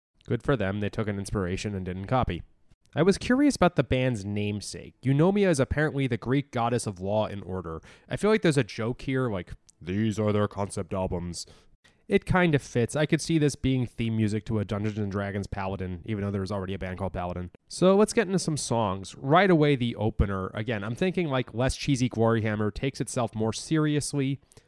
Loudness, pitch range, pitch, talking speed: -27 LUFS, 100-140 Hz, 115 Hz, 210 wpm